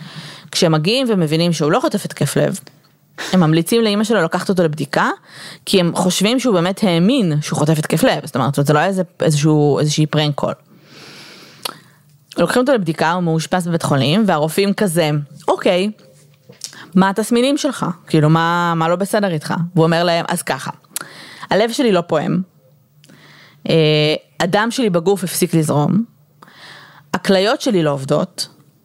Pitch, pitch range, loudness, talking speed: 170 Hz, 155-195 Hz, -16 LUFS, 150 wpm